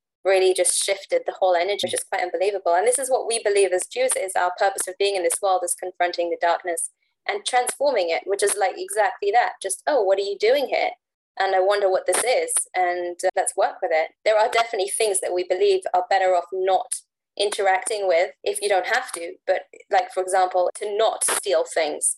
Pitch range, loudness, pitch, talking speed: 185-245 Hz, -22 LUFS, 195 Hz, 225 wpm